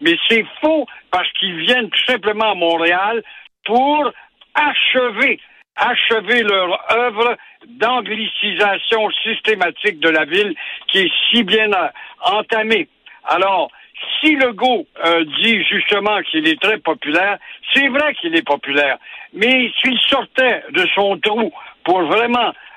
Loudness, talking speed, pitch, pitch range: -15 LUFS, 125 wpm, 220 Hz, 195-250 Hz